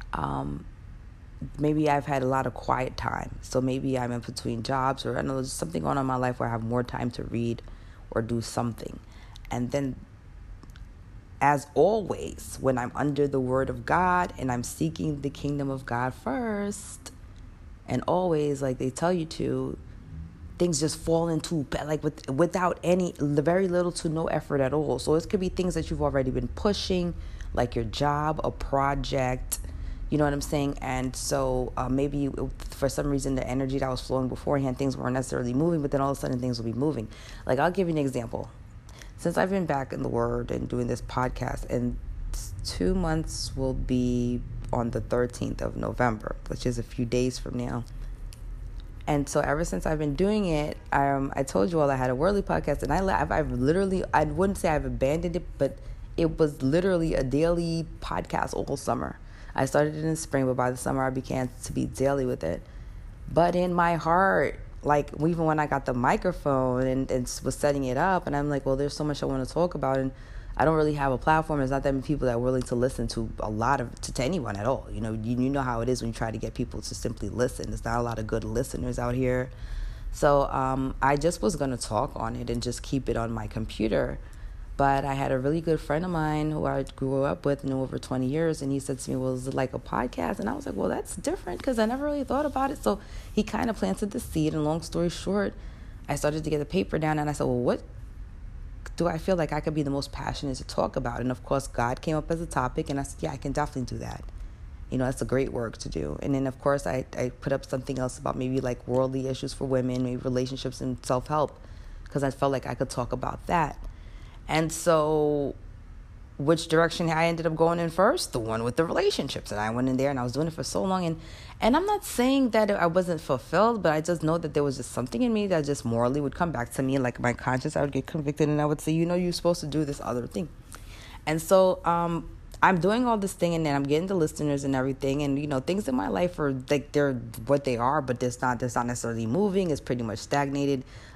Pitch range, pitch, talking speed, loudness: 120-155 Hz, 135 Hz, 240 wpm, -28 LUFS